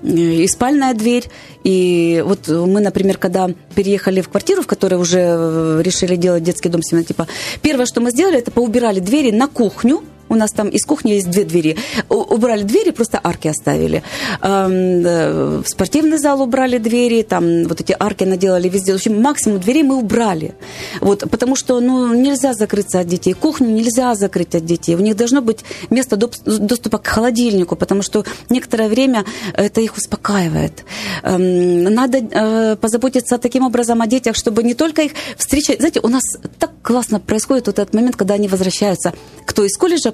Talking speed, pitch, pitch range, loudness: 165 wpm, 215 Hz, 185-250 Hz, -15 LUFS